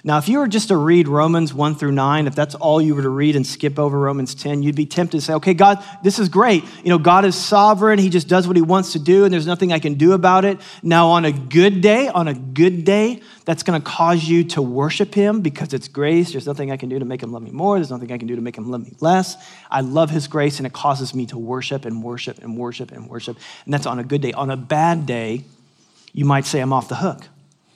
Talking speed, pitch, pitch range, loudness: 280 wpm, 155 Hz, 135-180 Hz, -17 LUFS